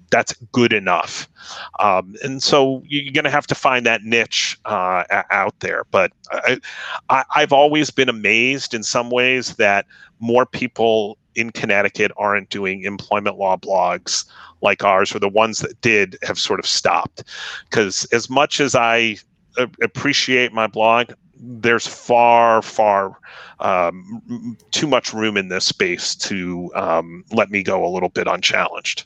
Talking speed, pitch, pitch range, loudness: 155 wpm, 115 Hz, 100-125 Hz, -18 LUFS